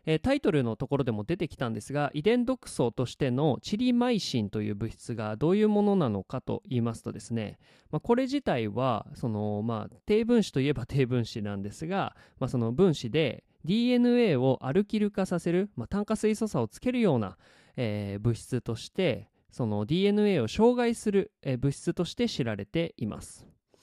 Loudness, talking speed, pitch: -29 LUFS, 365 characters per minute, 140 Hz